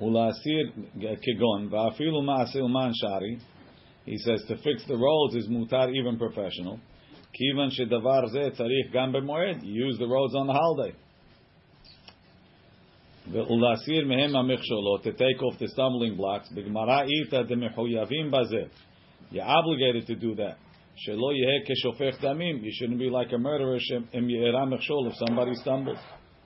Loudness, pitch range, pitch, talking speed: -27 LUFS, 115-135 Hz, 125 Hz, 85 wpm